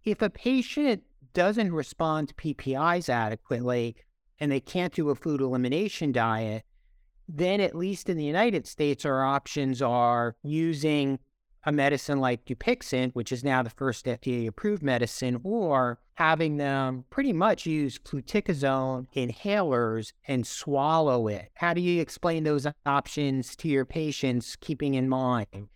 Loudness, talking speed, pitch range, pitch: -28 LUFS, 145 wpm, 125-165 Hz, 140 Hz